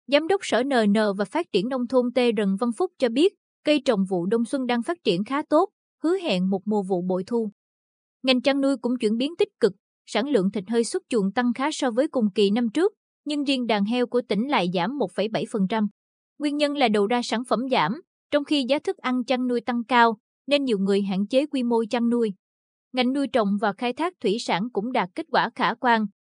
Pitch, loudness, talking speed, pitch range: 245 Hz, -24 LUFS, 235 wpm, 215-275 Hz